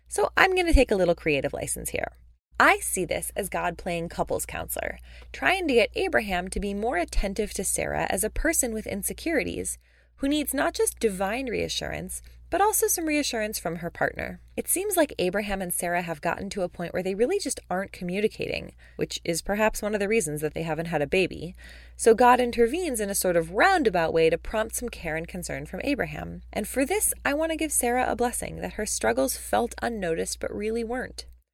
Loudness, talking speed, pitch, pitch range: -26 LUFS, 210 wpm, 210 Hz, 170-260 Hz